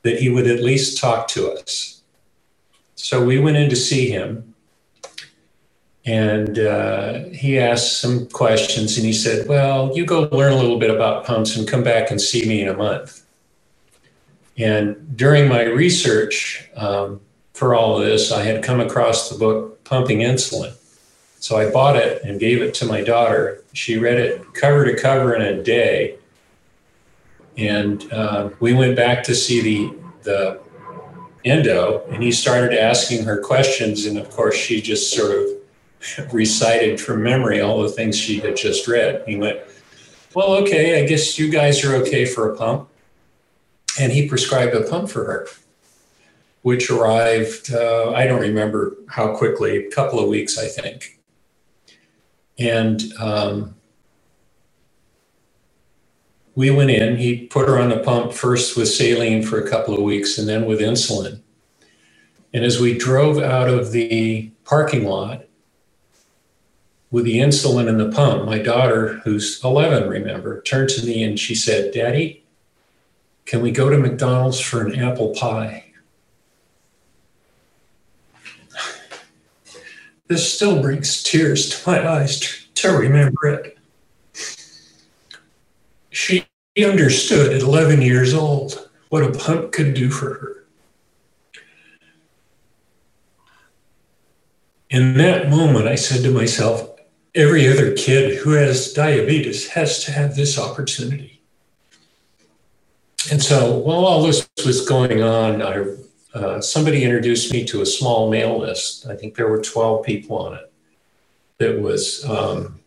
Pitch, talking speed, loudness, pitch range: 125 Hz, 145 wpm, -17 LUFS, 110-145 Hz